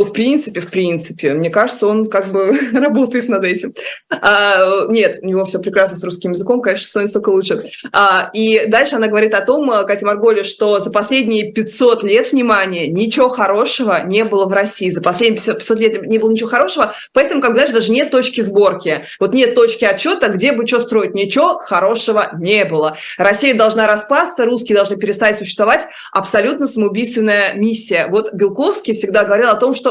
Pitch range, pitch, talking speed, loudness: 200-240 Hz, 215 Hz, 180 wpm, -14 LUFS